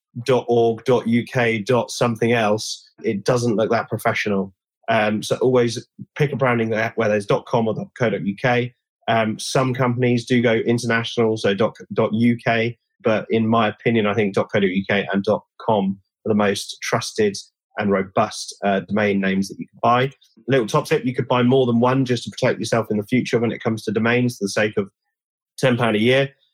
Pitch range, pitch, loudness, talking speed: 110-125 Hz, 115 Hz, -20 LUFS, 200 wpm